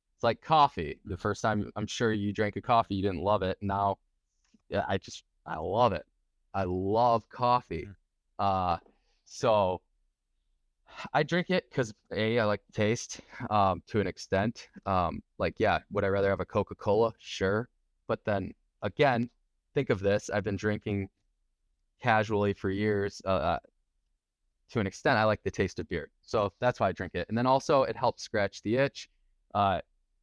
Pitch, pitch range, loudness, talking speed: 100 Hz, 90-110 Hz, -30 LUFS, 170 wpm